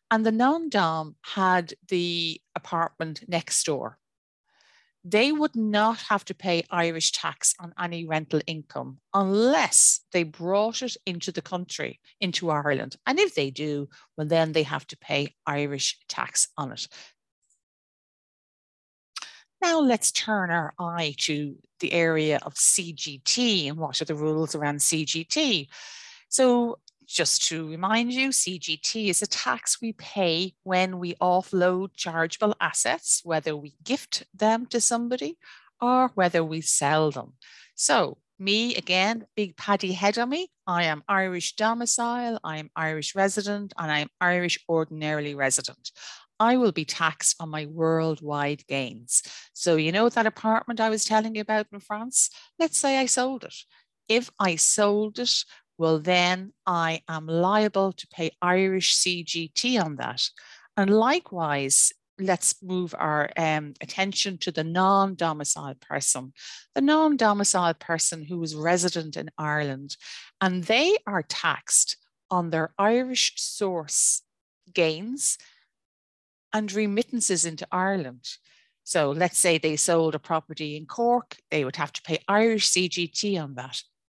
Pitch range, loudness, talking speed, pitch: 160-215 Hz, -25 LUFS, 145 wpm, 180 Hz